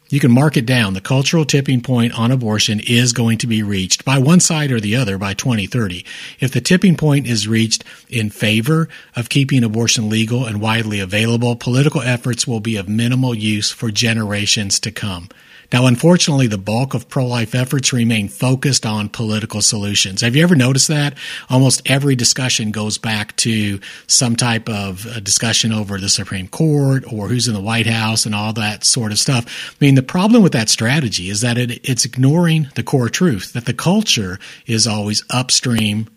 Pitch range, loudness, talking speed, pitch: 110-135 Hz, -15 LUFS, 190 wpm, 120 Hz